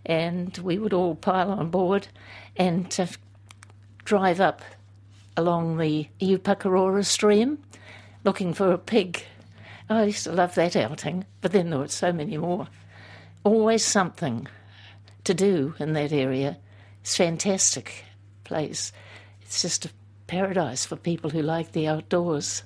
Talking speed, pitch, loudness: 145 wpm, 160 Hz, -25 LUFS